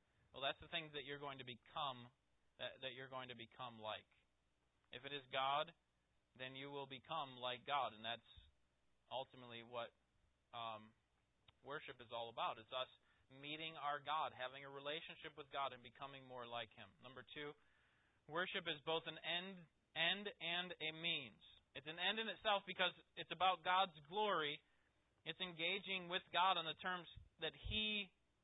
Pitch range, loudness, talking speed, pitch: 120-170 Hz, -46 LUFS, 170 wpm, 145 Hz